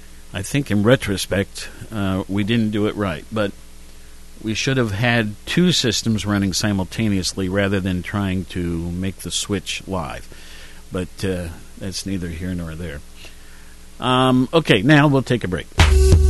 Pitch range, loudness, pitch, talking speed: 85-110 Hz, -20 LUFS, 95 Hz, 150 wpm